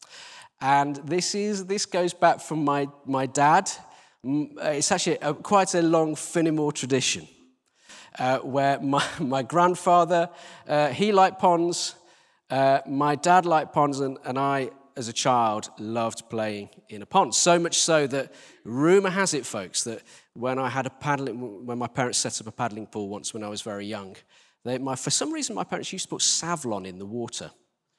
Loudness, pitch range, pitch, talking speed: -25 LUFS, 125-175 Hz, 145 Hz, 180 wpm